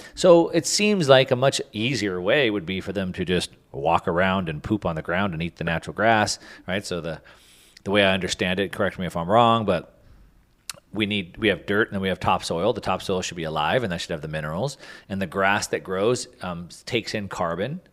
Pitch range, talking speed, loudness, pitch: 90-115 Hz, 235 wpm, -23 LUFS, 100 Hz